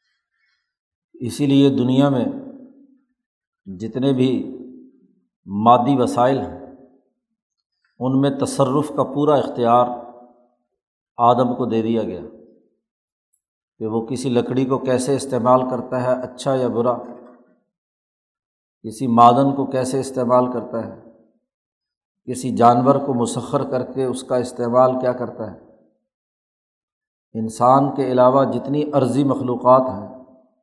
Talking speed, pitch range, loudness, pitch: 115 wpm, 120-135 Hz, -18 LUFS, 125 Hz